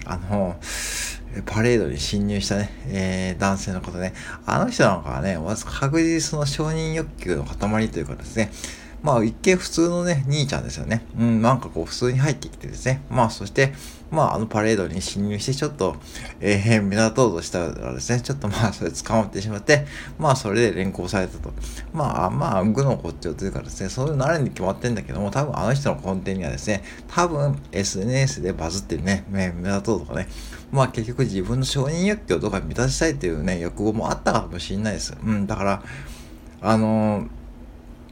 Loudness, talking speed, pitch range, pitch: -23 LUFS, 395 characters per minute, 95-130 Hz, 105 Hz